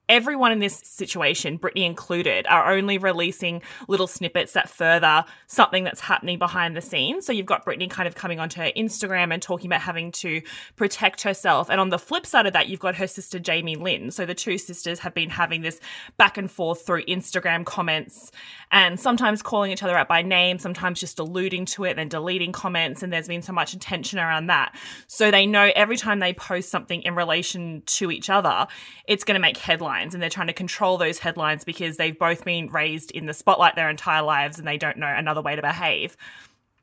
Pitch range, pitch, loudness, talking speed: 165-190 Hz, 180 Hz, -22 LUFS, 215 wpm